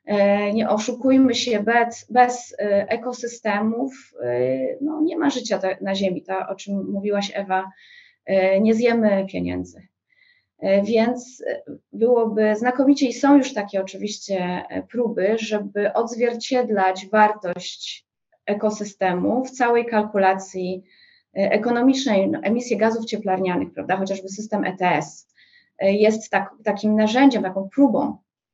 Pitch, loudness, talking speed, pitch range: 215 Hz, -21 LUFS, 105 wpm, 195-245 Hz